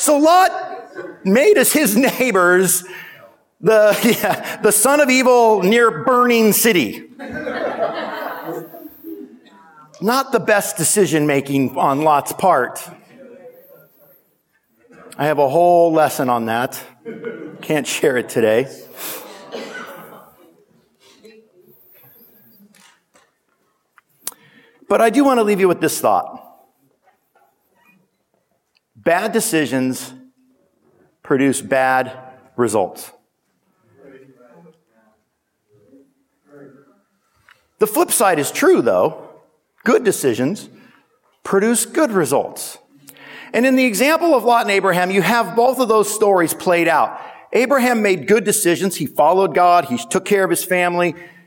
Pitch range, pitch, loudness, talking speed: 155-240 Hz, 200 Hz, -16 LUFS, 105 wpm